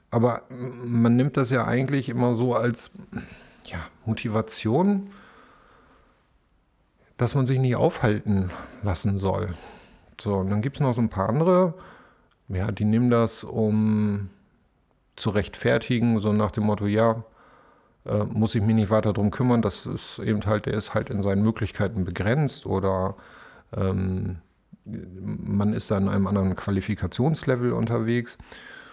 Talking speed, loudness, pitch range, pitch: 145 wpm, -25 LUFS, 100-120 Hz, 110 Hz